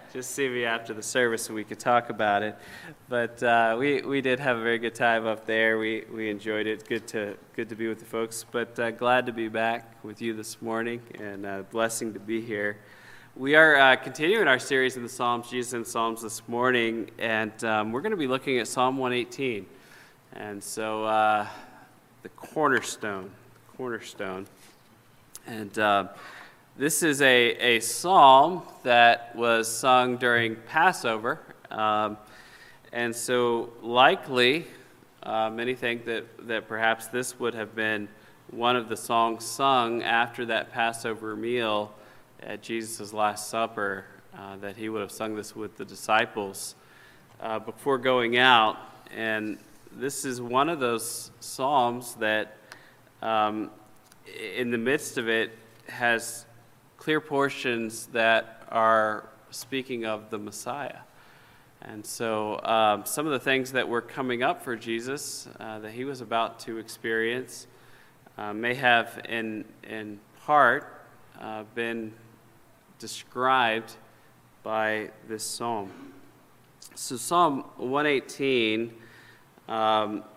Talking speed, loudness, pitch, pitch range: 145 wpm, -26 LUFS, 115 Hz, 110-125 Hz